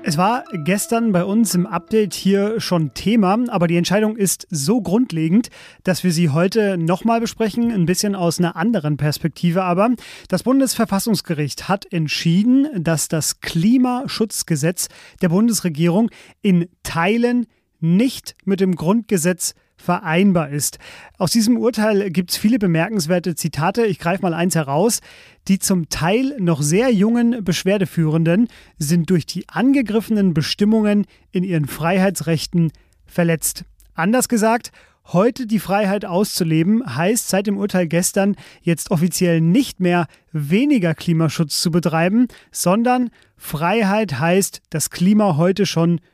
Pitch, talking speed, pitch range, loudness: 185 Hz, 130 wpm, 170-215 Hz, -18 LUFS